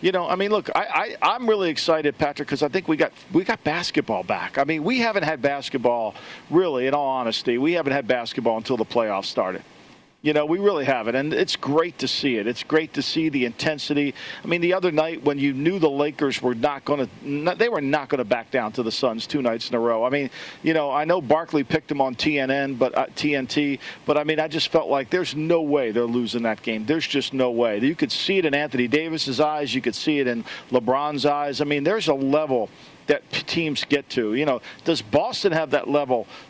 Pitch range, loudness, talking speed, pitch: 130-160 Hz, -23 LUFS, 245 wpm, 145 Hz